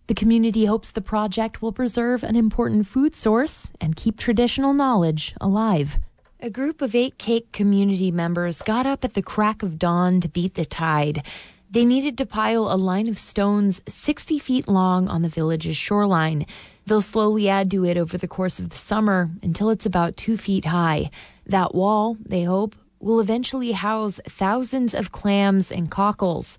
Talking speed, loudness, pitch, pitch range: 175 wpm, -22 LUFS, 205 Hz, 180-225 Hz